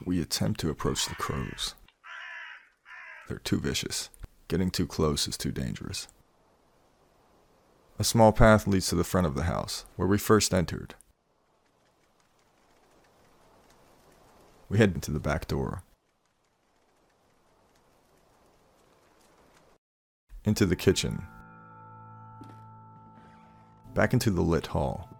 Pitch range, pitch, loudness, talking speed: 85-110 Hz, 95 Hz, -28 LUFS, 100 wpm